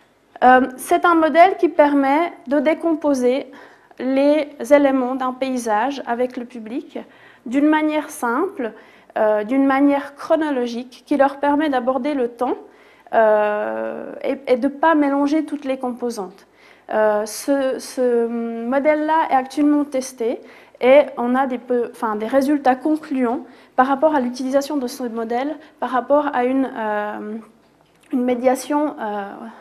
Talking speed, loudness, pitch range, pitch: 140 wpm, -19 LUFS, 240-295 Hz, 265 Hz